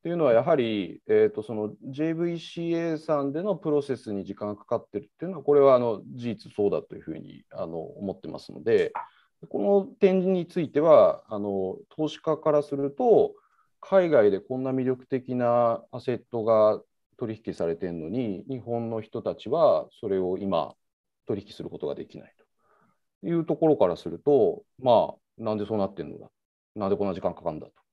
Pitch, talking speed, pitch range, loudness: 130 Hz, 355 characters per minute, 110-170 Hz, -26 LUFS